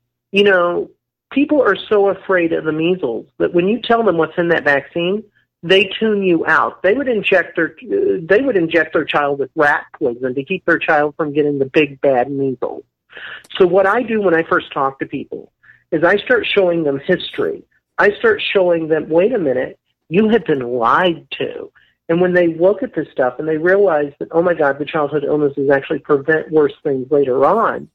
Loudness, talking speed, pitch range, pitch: -16 LUFS, 205 wpm, 150-200 Hz, 170 Hz